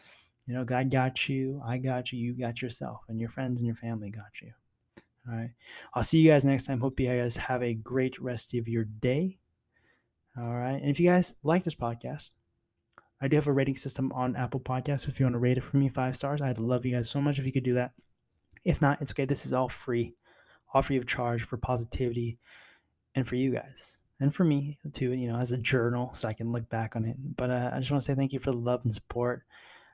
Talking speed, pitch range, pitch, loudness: 250 wpm, 120-135 Hz, 125 Hz, -30 LUFS